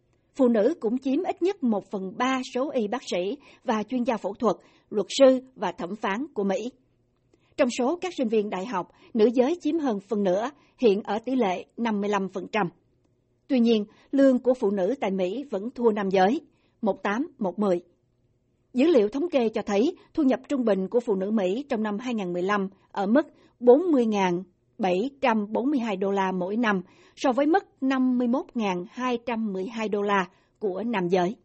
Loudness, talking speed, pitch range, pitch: -26 LUFS, 175 wpm, 195-260 Hz, 225 Hz